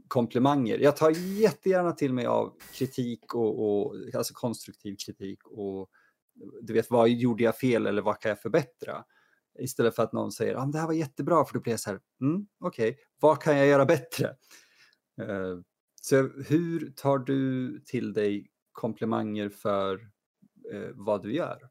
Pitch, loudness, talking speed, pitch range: 120 Hz, -28 LUFS, 175 wpm, 105-140 Hz